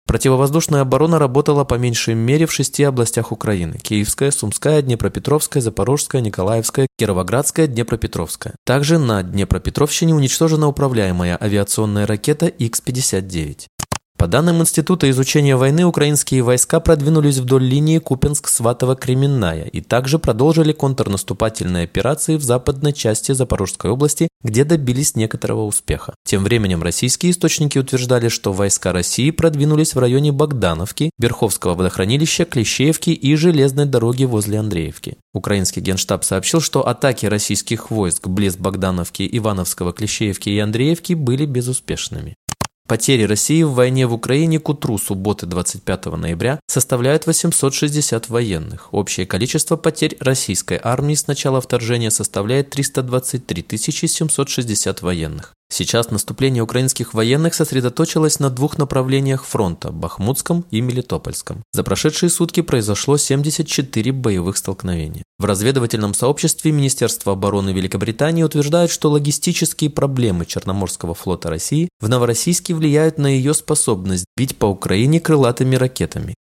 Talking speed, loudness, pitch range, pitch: 120 wpm, -17 LUFS, 105-150 Hz, 125 Hz